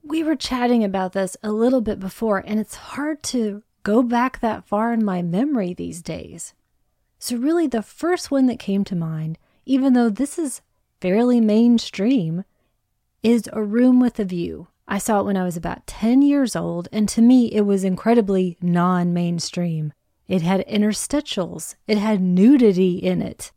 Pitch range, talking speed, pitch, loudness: 185-245 Hz, 175 wpm, 215 Hz, -20 LUFS